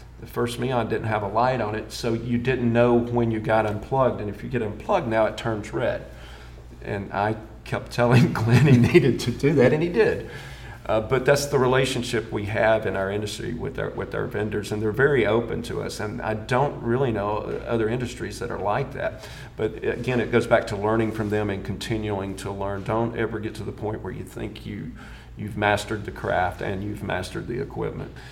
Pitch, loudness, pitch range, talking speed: 110 Hz, -24 LUFS, 105-120 Hz, 220 wpm